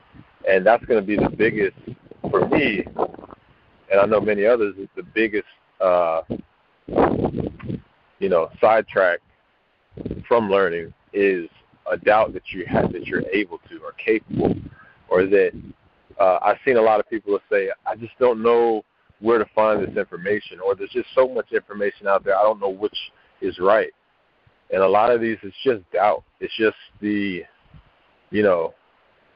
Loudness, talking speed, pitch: -21 LUFS, 165 wpm, 325 Hz